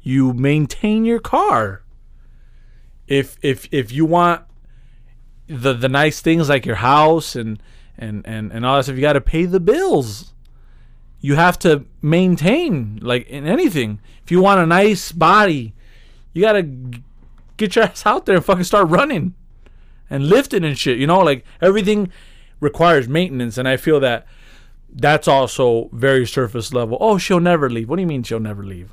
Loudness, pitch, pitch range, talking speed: -16 LUFS, 145 Hz, 125-180 Hz, 170 wpm